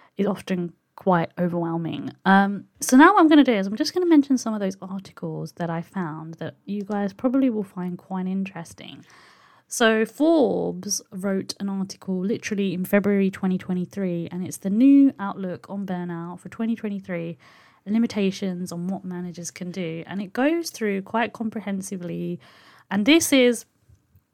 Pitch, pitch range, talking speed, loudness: 195 Hz, 175-220 Hz, 165 wpm, -23 LUFS